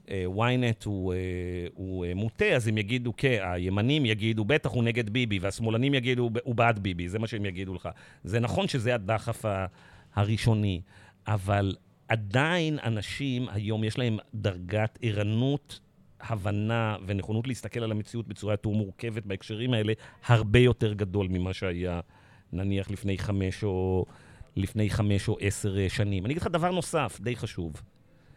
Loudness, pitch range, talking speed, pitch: -29 LUFS, 95-120 Hz, 140 wpm, 110 Hz